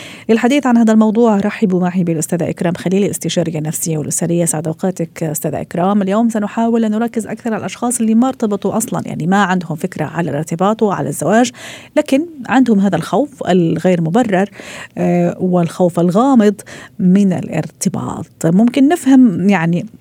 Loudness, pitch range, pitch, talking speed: -15 LUFS, 170-225 Hz, 195 Hz, 140 wpm